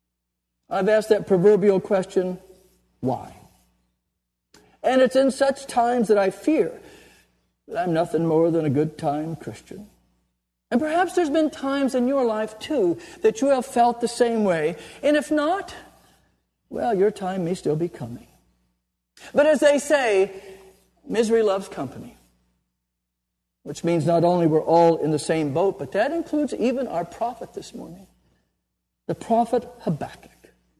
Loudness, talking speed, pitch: -22 LUFS, 150 wpm, 190 Hz